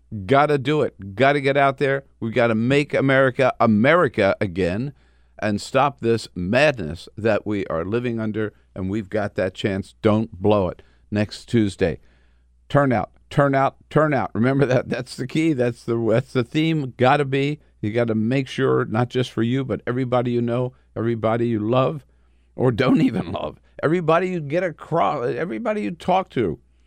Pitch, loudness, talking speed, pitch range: 120 Hz, -21 LUFS, 175 wpm, 105-135 Hz